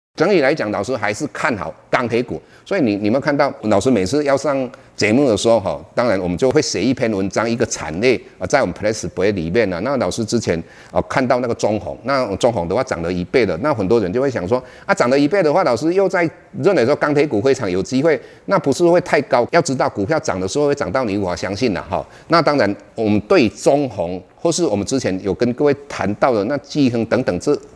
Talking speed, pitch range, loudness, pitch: 360 characters per minute, 100-145 Hz, -18 LUFS, 125 Hz